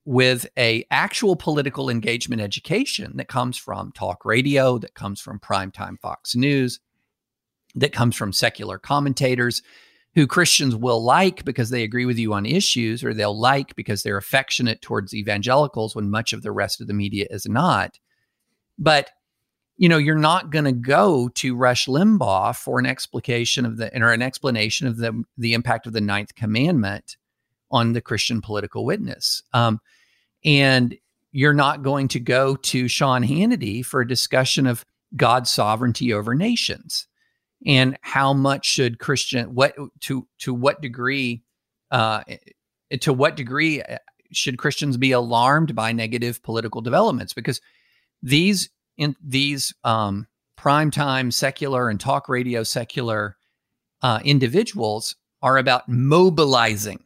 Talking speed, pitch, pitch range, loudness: 145 wpm, 125 Hz, 115-140 Hz, -20 LUFS